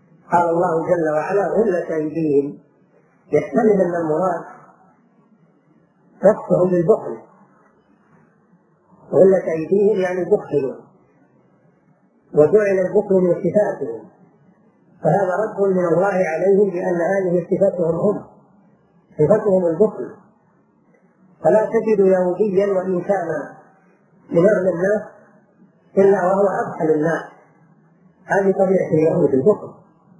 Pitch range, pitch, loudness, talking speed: 170-200 Hz, 185 Hz, -18 LUFS, 85 wpm